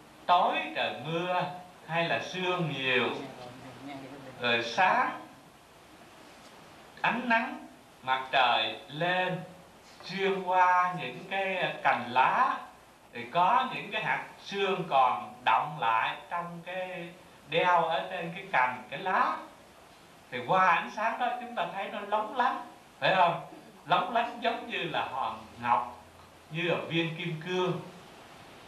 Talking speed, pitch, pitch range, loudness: 130 wpm, 180 Hz, 150-185 Hz, -29 LUFS